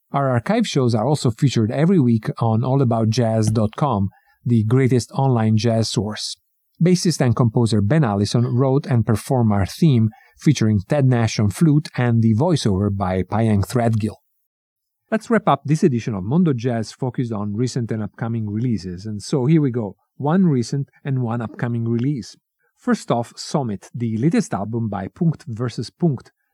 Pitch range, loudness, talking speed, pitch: 110-140 Hz, -20 LUFS, 160 wpm, 120 Hz